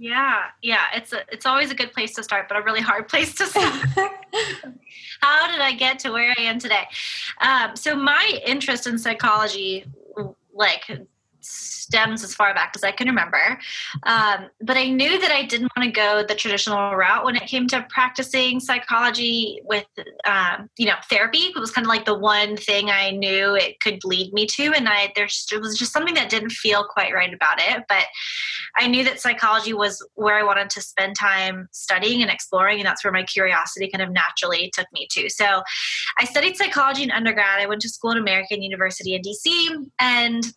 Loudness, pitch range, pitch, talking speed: -20 LUFS, 205-260 Hz, 225 Hz, 205 wpm